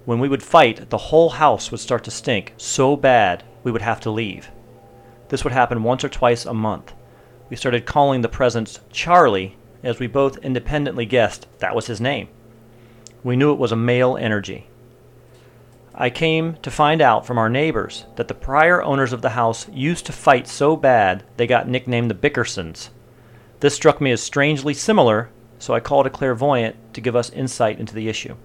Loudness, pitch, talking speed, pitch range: -19 LUFS, 120 Hz, 190 wpm, 115-140 Hz